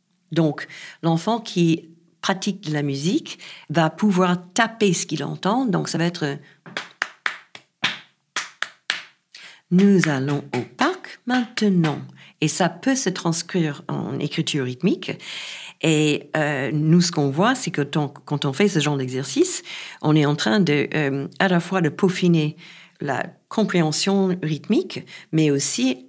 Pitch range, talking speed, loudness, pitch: 150-190 Hz, 140 wpm, -22 LUFS, 165 Hz